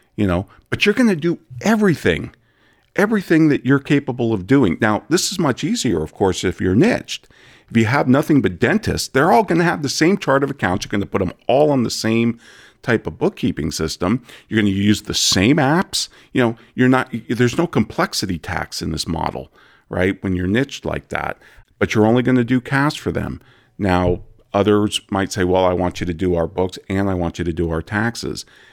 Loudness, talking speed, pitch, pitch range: -18 LUFS, 220 wpm, 110 Hz, 90-135 Hz